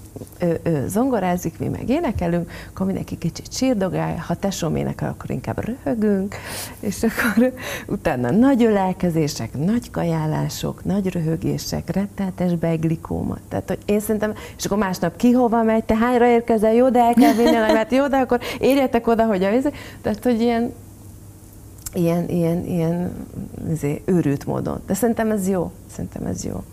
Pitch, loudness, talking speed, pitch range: 190 Hz, -21 LUFS, 155 wpm, 165-230 Hz